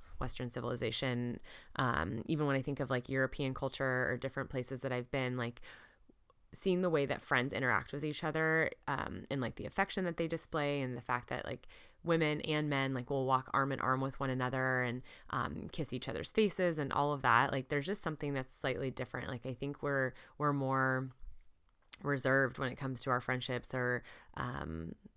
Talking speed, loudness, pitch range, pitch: 200 wpm, -36 LUFS, 125-145 Hz, 135 Hz